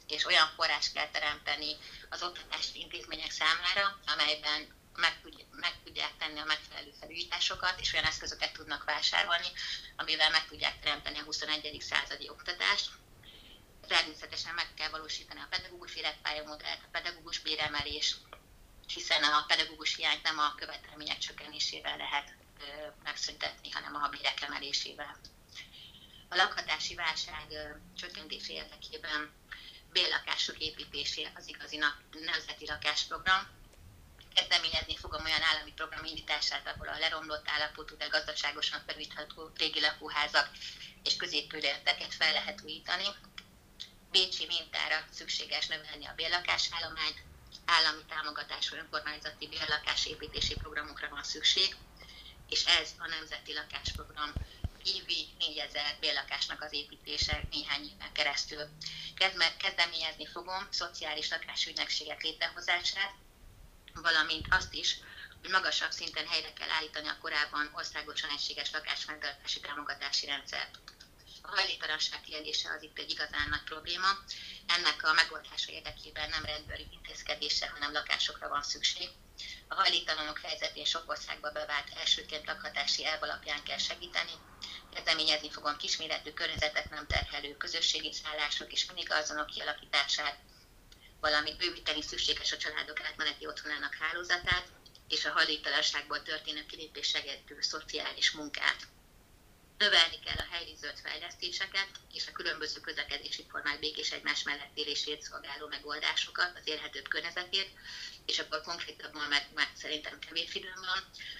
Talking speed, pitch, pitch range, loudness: 120 wpm, 155 Hz, 150-165 Hz, -32 LUFS